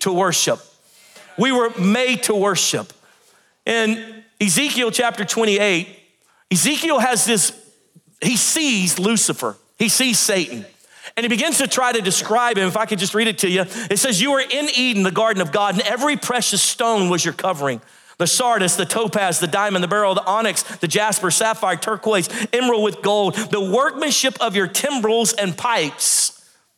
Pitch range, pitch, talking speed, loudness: 195-235 Hz, 215 Hz, 175 wpm, -18 LUFS